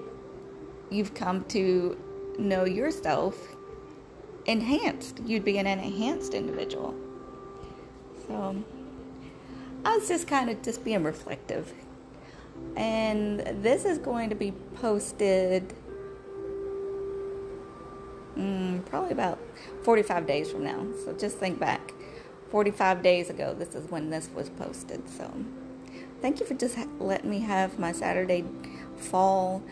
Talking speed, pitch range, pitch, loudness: 120 wpm, 185-275 Hz, 210 Hz, -30 LUFS